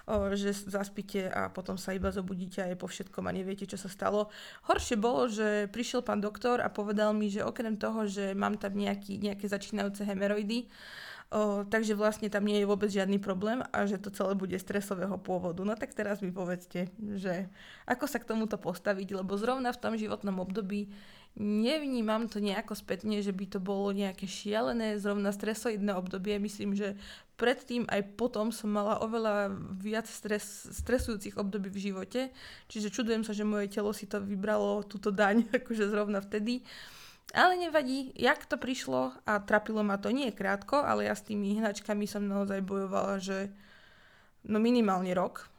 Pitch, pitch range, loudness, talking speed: 205 Hz, 200-220 Hz, -33 LUFS, 170 wpm